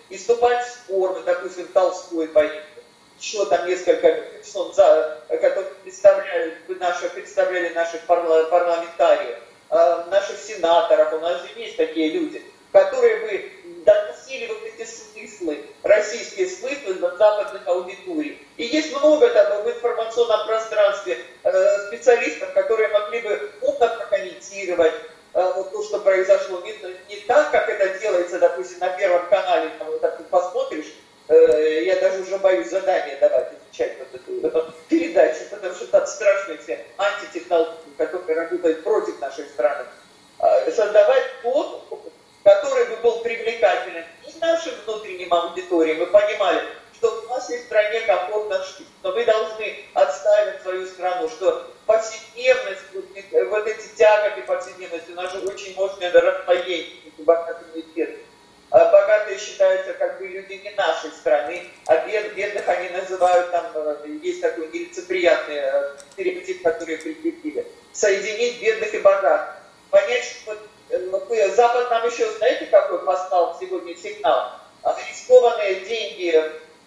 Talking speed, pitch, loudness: 130 wpm, 210 Hz, -21 LUFS